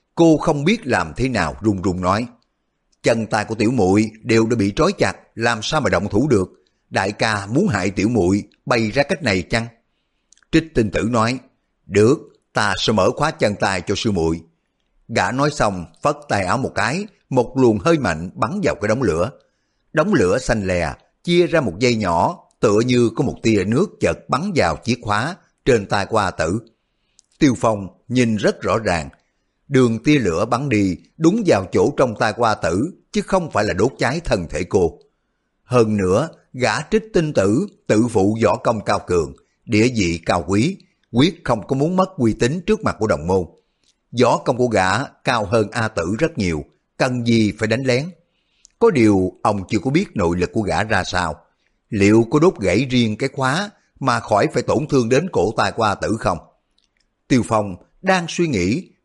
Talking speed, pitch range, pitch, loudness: 200 wpm, 105-145 Hz, 115 Hz, -19 LUFS